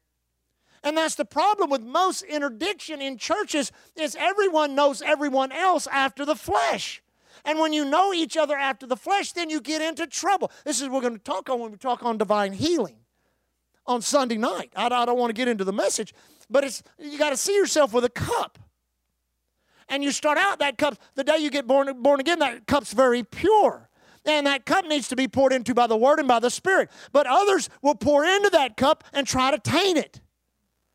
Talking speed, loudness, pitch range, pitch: 215 wpm, -23 LUFS, 250-310 Hz, 285 Hz